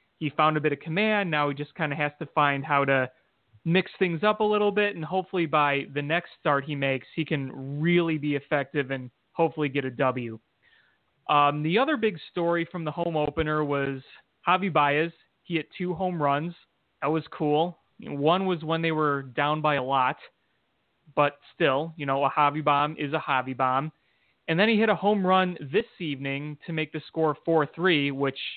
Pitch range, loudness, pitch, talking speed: 145-170 Hz, -26 LUFS, 150 Hz, 200 wpm